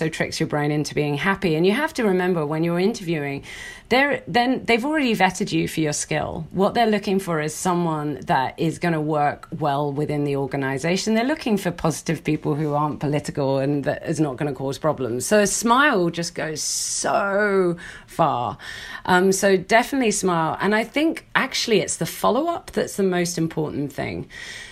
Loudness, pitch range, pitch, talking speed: -22 LUFS, 150-200 Hz, 165 Hz, 205 wpm